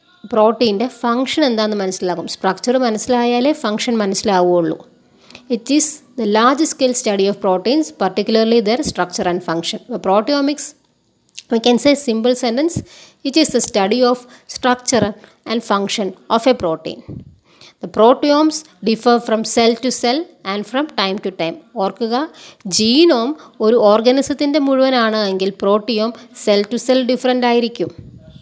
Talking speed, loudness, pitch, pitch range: 130 wpm, -16 LUFS, 230 Hz, 205-255 Hz